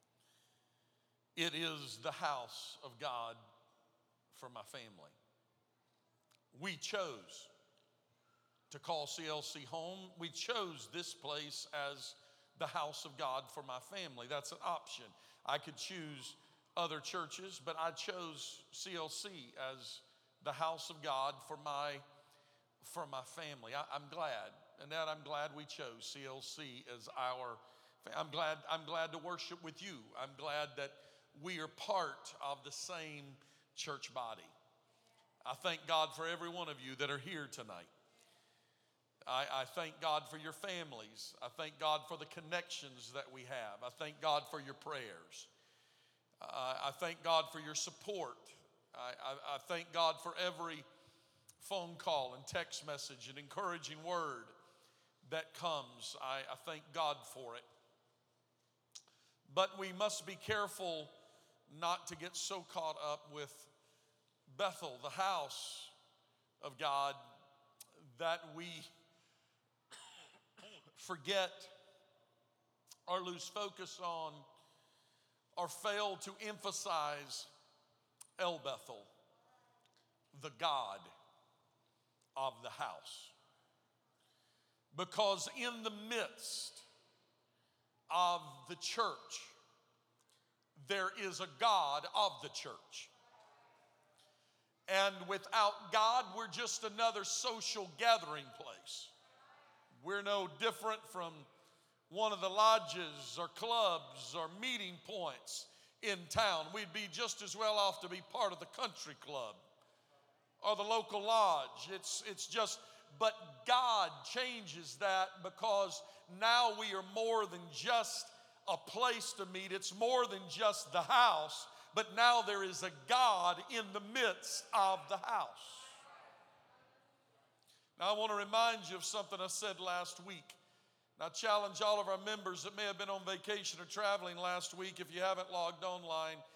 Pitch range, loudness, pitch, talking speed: 145-200 Hz, -40 LUFS, 170 Hz, 135 wpm